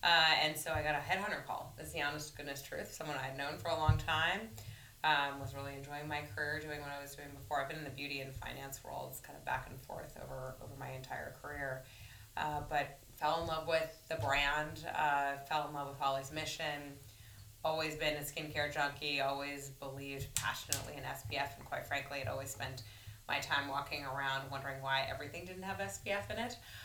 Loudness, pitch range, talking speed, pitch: -38 LUFS, 135-150 Hz, 210 wpm, 140 Hz